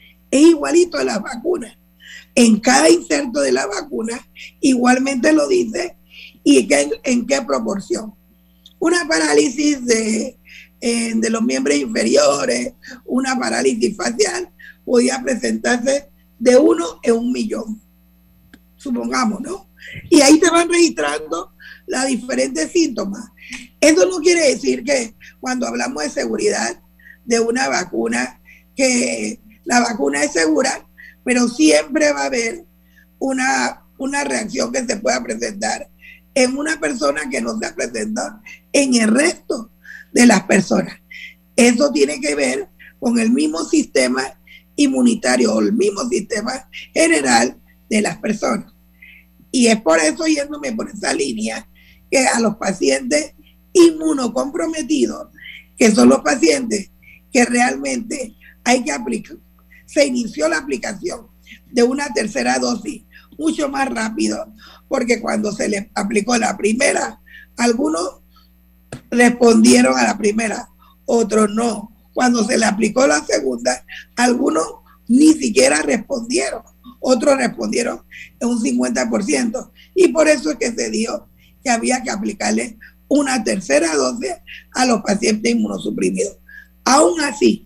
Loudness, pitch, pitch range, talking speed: -17 LUFS, 240 Hz, 185-275 Hz, 130 wpm